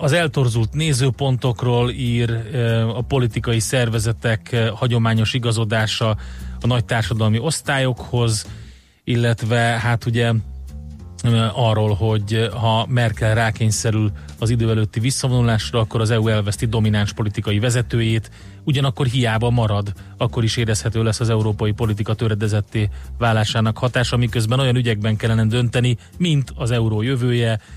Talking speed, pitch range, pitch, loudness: 115 wpm, 110-120 Hz, 115 Hz, -19 LUFS